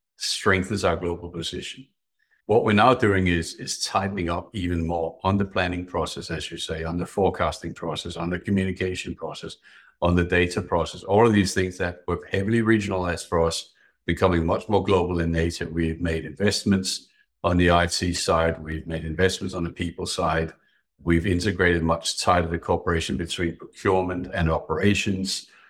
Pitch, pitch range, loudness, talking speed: 90 Hz, 85-95 Hz, -24 LUFS, 170 wpm